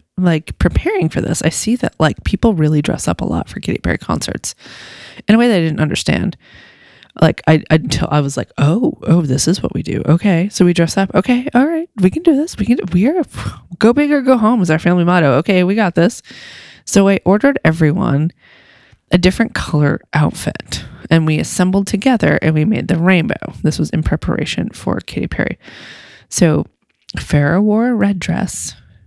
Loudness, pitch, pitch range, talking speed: -15 LUFS, 185 Hz, 160-225 Hz, 200 wpm